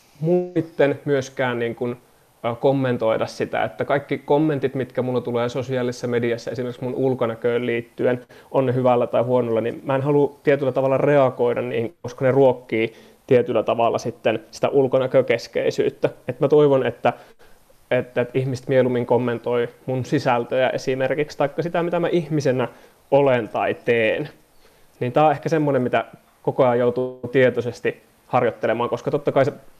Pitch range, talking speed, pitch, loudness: 120-140 Hz, 145 wpm, 130 Hz, -21 LUFS